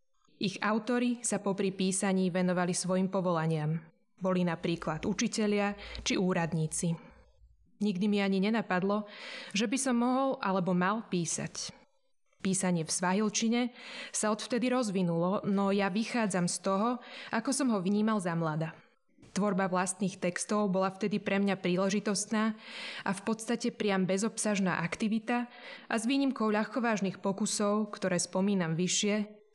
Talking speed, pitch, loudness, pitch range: 130 wpm, 205 Hz, -31 LUFS, 185-225 Hz